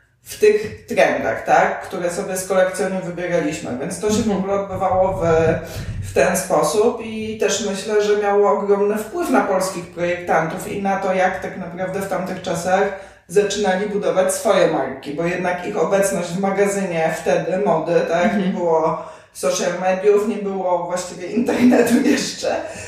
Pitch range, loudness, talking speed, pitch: 180-205 Hz, -19 LUFS, 155 wpm, 190 Hz